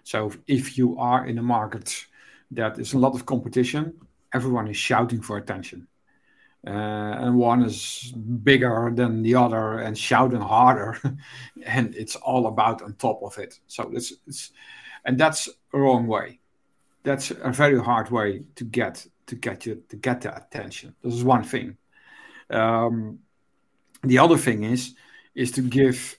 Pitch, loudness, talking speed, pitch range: 125 Hz, -23 LUFS, 165 wpm, 115-130 Hz